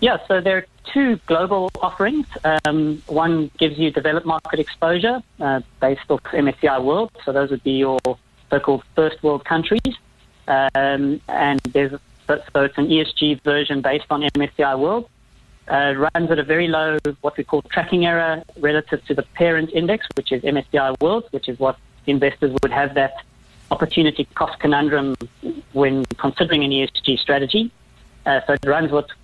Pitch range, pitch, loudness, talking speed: 140-165 Hz, 150 Hz, -19 LUFS, 170 wpm